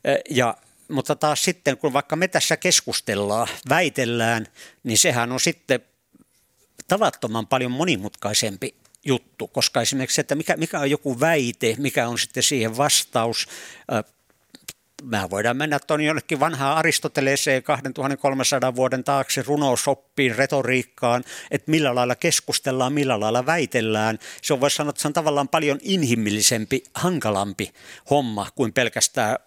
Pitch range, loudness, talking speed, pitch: 125-150 Hz, -22 LUFS, 130 wpm, 135 Hz